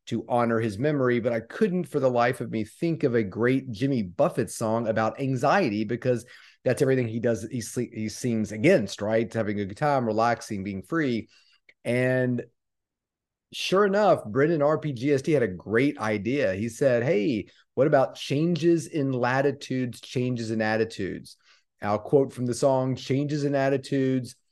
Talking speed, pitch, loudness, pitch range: 160 wpm, 125 Hz, -26 LUFS, 115-140 Hz